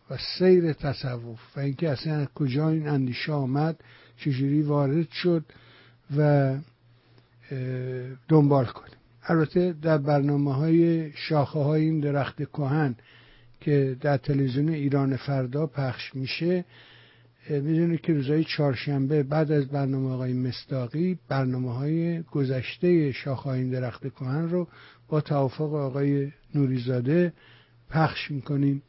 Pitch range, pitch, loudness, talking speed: 130-155 Hz, 140 Hz, -26 LUFS, 115 wpm